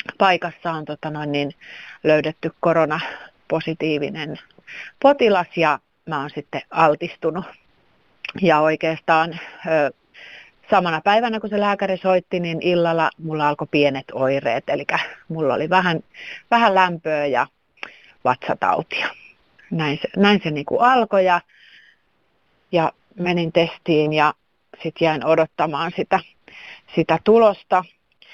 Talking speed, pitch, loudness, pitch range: 110 wpm, 165 Hz, -20 LUFS, 155-185 Hz